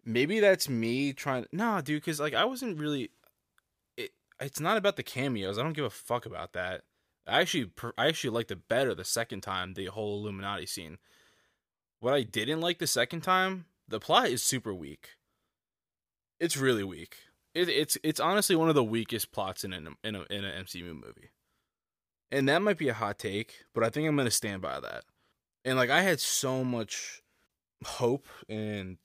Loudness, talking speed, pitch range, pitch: -30 LUFS, 195 wpm, 100-160 Hz, 130 Hz